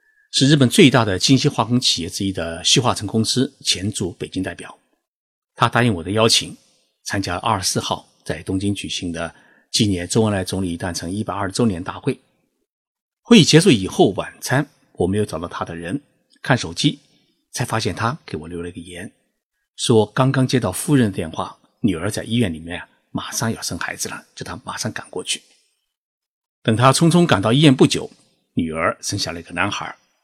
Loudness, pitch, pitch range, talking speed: -19 LUFS, 110 Hz, 95-130 Hz, 280 characters per minute